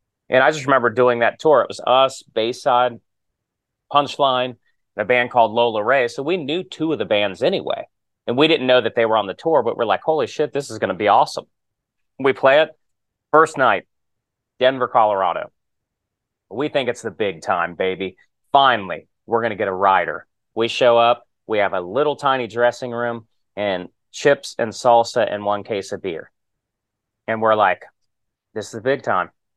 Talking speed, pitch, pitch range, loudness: 195 wpm, 120 Hz, 110-130 Hz, -19 LUFS